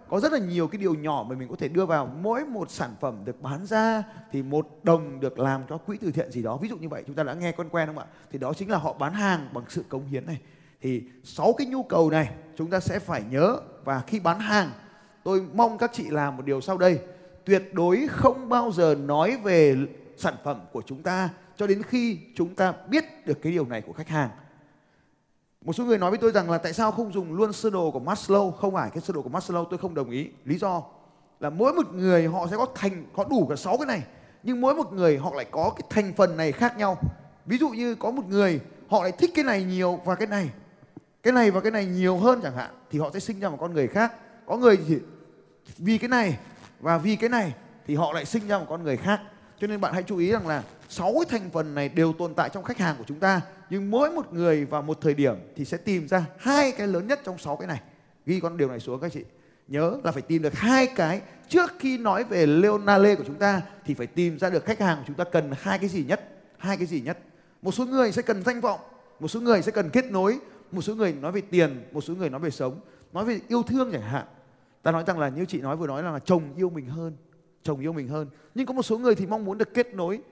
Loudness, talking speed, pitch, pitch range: -26 LUFS, 265 wpm, 180 Hz, 155-210 Hz